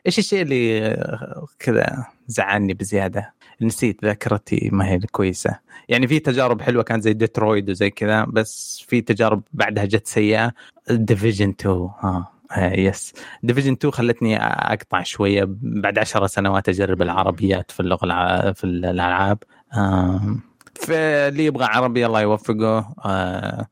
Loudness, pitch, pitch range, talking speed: -20 LUFS, 105 Hz, 95-120 Hz, 135 wpm